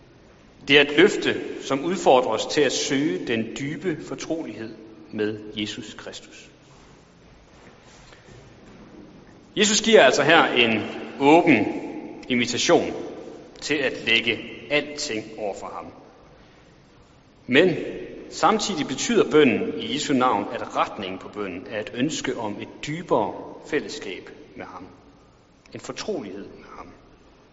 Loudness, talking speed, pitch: -22 LUFS, 115 wpm, 135 Hz